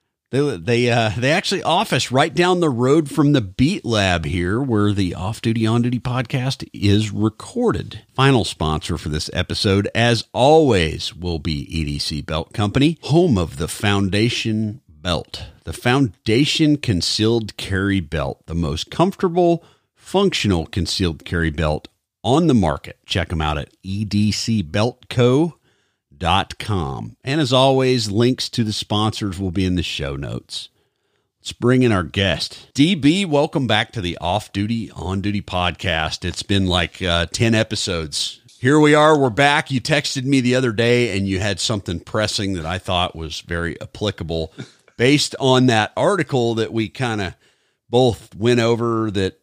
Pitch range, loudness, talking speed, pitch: 90-130 Hz, -19 LUFS, 155 wpm, 110 Hz